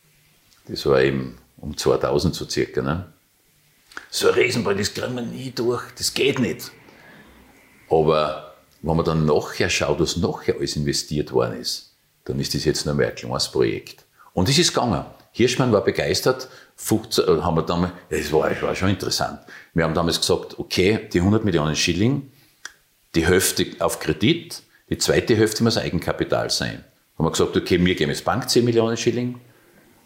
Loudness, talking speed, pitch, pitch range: -21 LUFS, 175 wpm, 90 Hz, 75-115 Hz